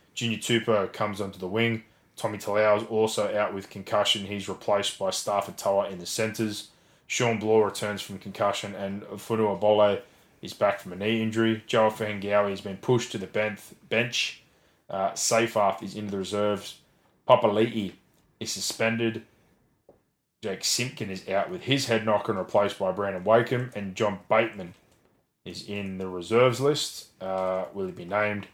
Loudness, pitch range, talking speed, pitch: -27 LUFS, 100-115 Hz, 165 wpm, 105 Hz